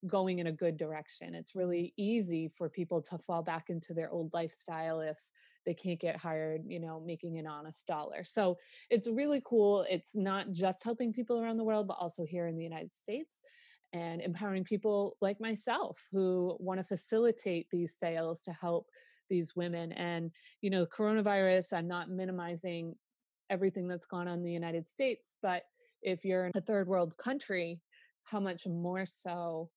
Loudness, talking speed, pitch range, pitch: -36 LUFS, 180 wpm, 170-200 Hz, 180 Hz